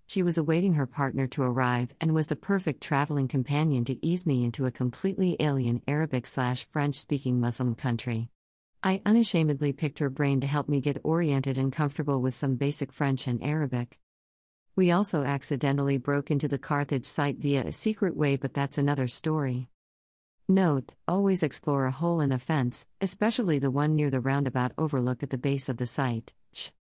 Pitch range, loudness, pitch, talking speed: 130-155 Hz, -28 LUFS, 140 Hz, 180 wpm